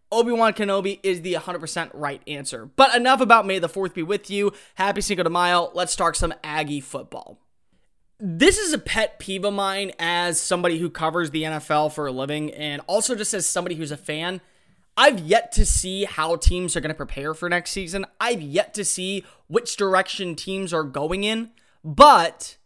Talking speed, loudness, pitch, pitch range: 195 wpm, -22 LUFS, 180 Hz, 155-200 Hz